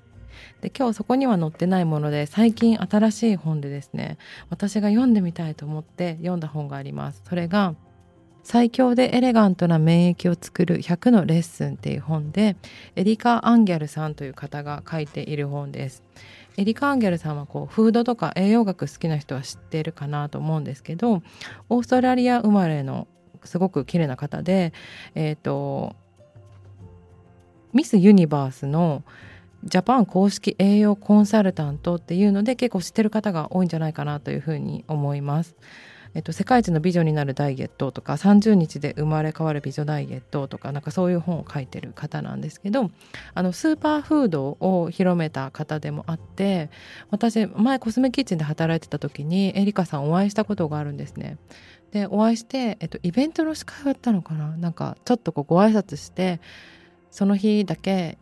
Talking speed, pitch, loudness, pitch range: 340 characters per minute, 170 Hz, -22 LUFS, 150-210 Hz